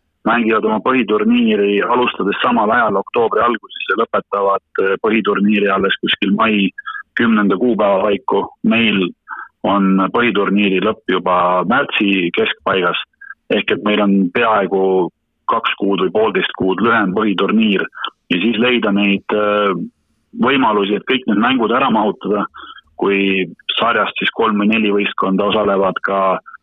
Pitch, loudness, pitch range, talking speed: 100 Hz, -15 LUFS, 95-115 Hz, 125 wpm